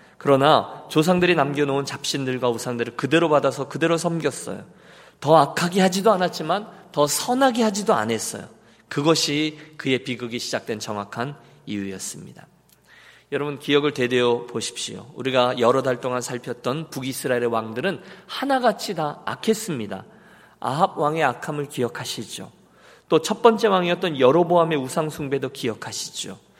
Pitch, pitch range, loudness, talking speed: 145 Hz, 125-170 Hz, -22 LUFS, 345 characters per minute